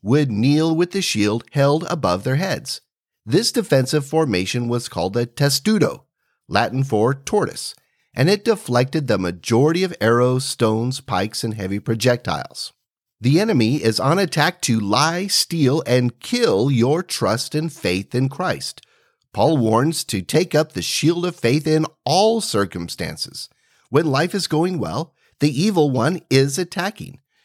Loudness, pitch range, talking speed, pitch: -19 LUFS, 115-165 Hz, 150 wpm, 140 Hz